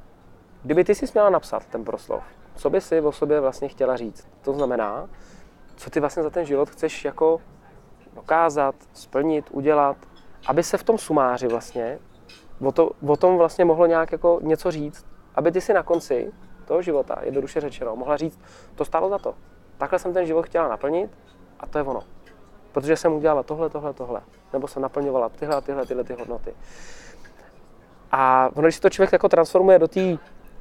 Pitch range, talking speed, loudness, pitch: 135-170 Hz, 180 wpm, -22 LUFS, 150 Hz